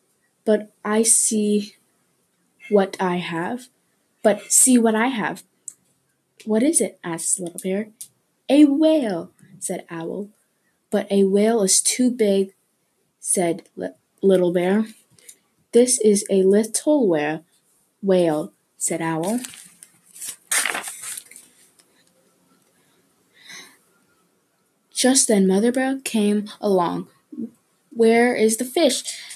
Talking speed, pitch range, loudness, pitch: 100 wpm, 185-230 Hz, -20 LUFS, 210 Hz